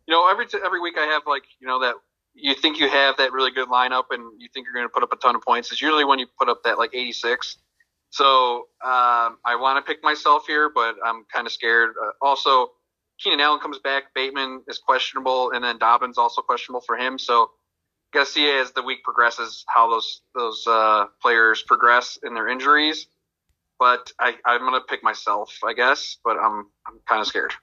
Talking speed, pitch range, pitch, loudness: 215 wpm, 120-150 Hz, 130 Hz, -20 LUFS